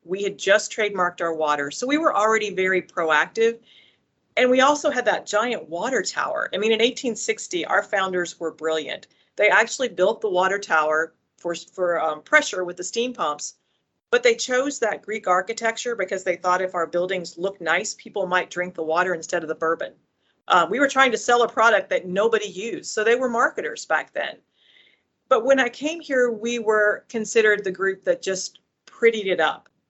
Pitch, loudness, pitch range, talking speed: 205 Hz, -22 LUFS, 180-235 Hz, 195 wpm